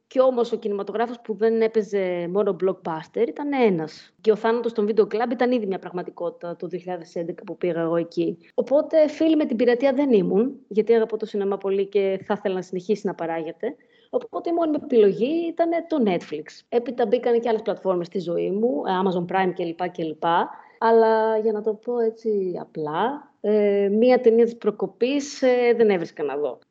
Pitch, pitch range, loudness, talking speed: 220 Hz, 185-245 Hz, -23 LUFS, 185 wpm